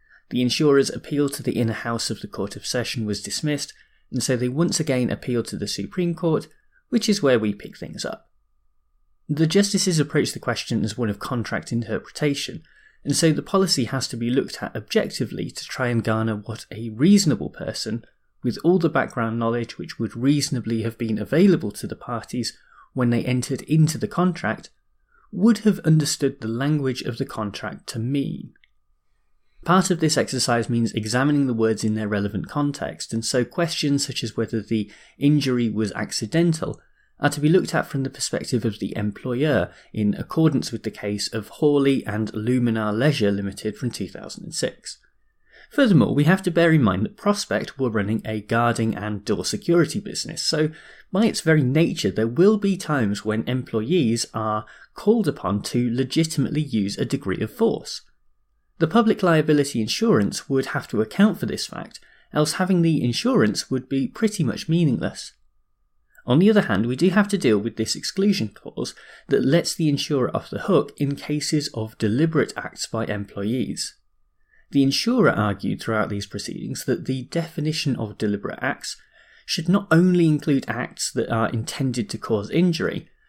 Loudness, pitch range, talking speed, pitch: -22 LUFS, 110-160 Hz, 175 wpm, 130 Hz